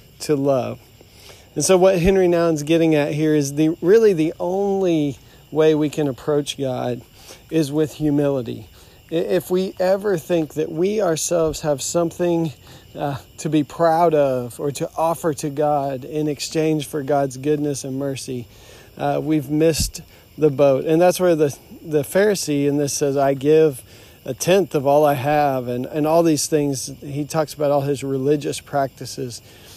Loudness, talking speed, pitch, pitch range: -20 LUFS, 175 wpm, 150 Hz, 135-160 Hz